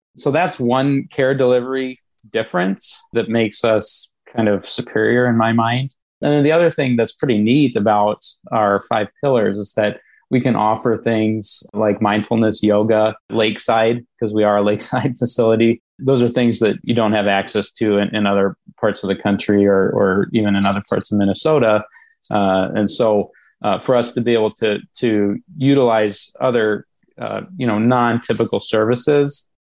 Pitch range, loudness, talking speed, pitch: 105-125 Hz, -17 LUFS, 170 wpm, 110 Hz